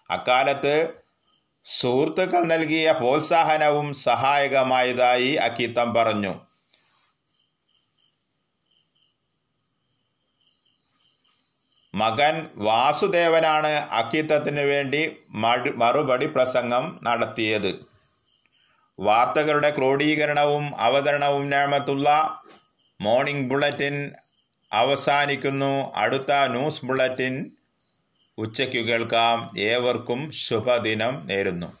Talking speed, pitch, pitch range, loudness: 55 wpm, 140 Hz, 125-150 Hz, -22 LUFS